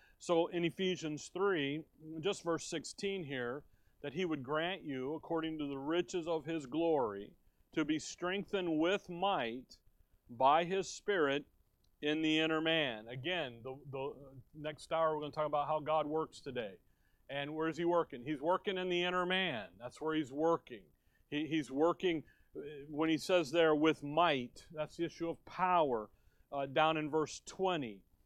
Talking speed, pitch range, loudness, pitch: 170 wpm, 145-170 Hz, -36 LUFS, 155 Hz